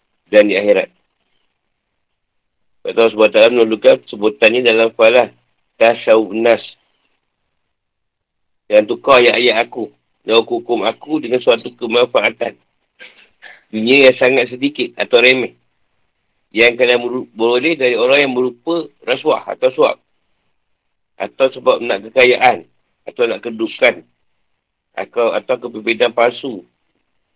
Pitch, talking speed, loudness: 125 Hz, 115 wpm, -13 LUFS